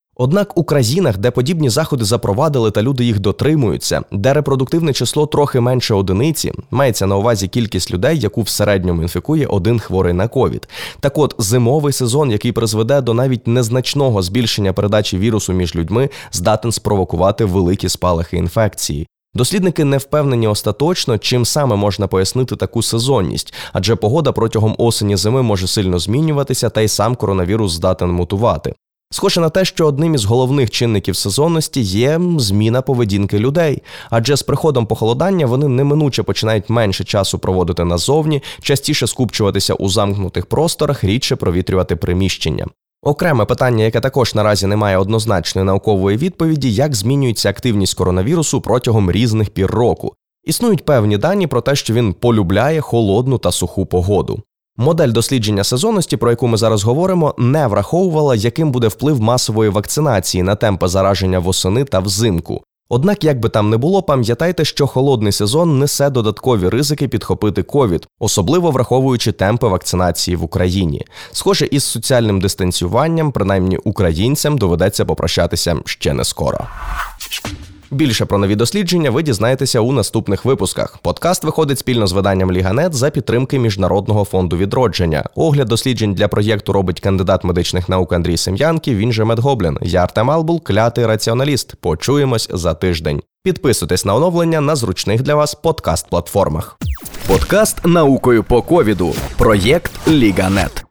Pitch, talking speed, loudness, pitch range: 115 Hz, 145 wpm, -15 LUFS, 100-140 Hz